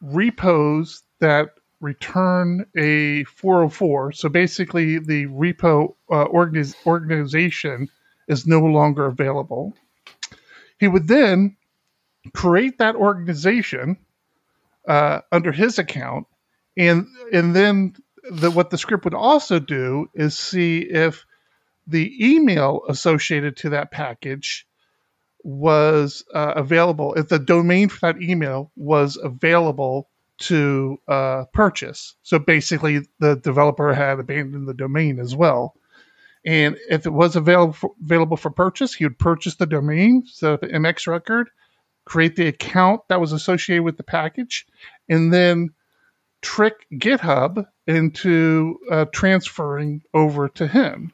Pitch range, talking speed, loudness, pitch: 150-185 Hz, 125 wpm, -19 LUFS, 165 Hz